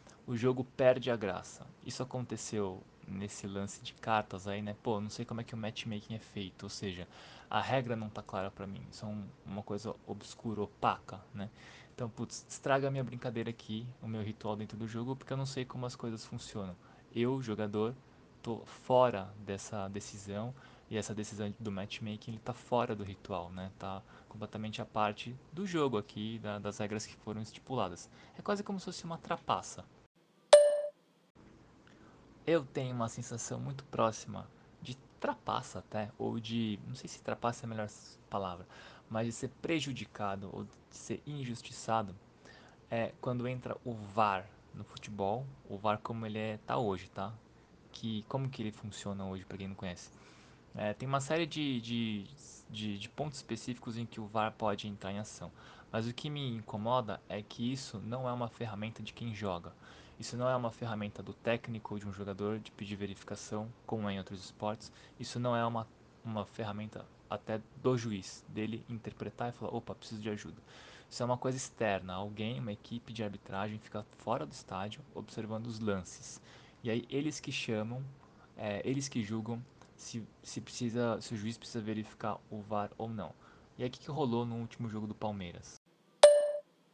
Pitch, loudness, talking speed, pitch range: 110 Hz, -37 LUFS, 185 wpm, 105-125 Hz